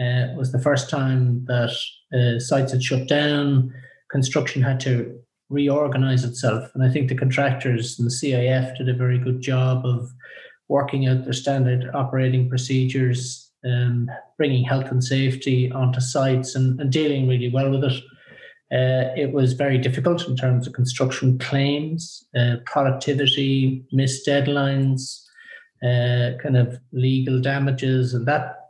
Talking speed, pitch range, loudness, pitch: 150 wpm, 125-140 Hz, -21 LUFS, 130 Hz